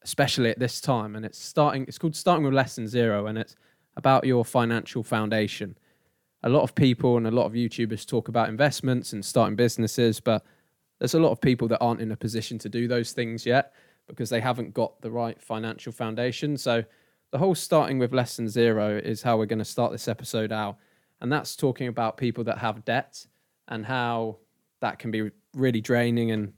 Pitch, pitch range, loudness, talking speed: 120 Hz, 110-125 Hz, -26 LUFS, 205 wpm